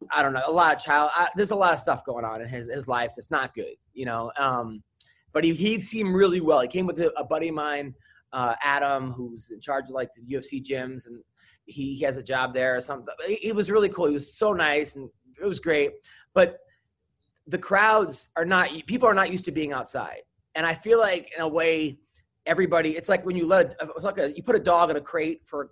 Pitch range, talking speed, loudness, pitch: 130-185 Hz, 250 wpm, -25 LUFS, 155 Hz